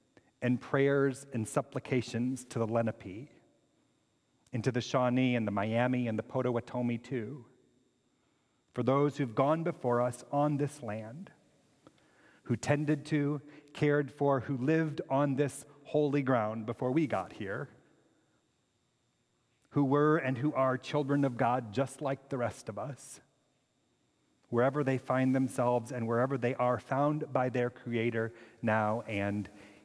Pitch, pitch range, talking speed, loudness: 130 Hz, 120-145 Hz, 140 wpm, -32 LUFS